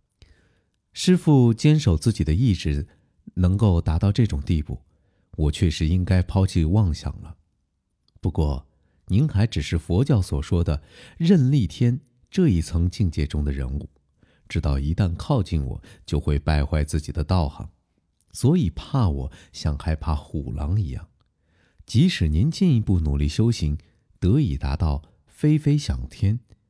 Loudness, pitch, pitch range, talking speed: -23 LUFS, 90 Hz, 75-110 Hz, 215 characters per minute